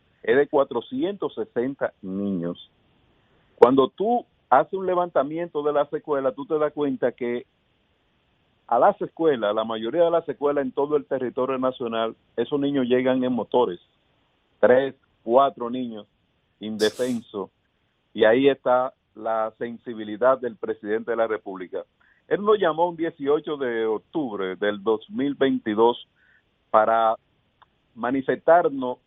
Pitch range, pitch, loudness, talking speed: 115-150 Hz, 130 Hz, -23 LUFS, 125 wpm